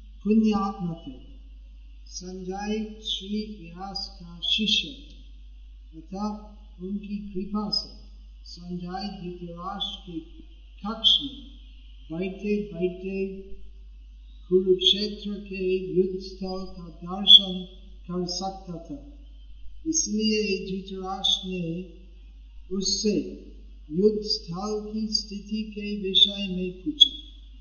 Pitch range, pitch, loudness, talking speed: 180-210 Hz, 190 Hz, -24 LUFS, 75 wpm